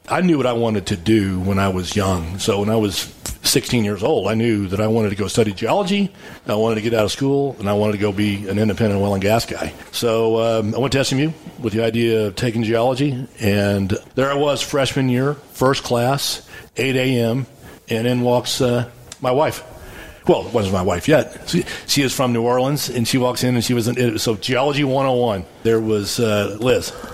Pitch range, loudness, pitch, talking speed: 105-130 Hz, -19 LUFS, 115 Hz, 225 wpm